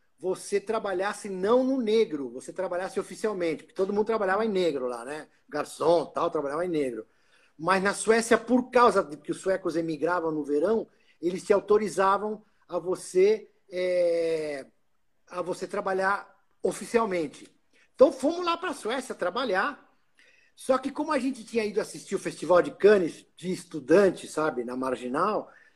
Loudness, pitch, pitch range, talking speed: -27 LUFS, 190 Hz, 170-225 Hz, 155 wpm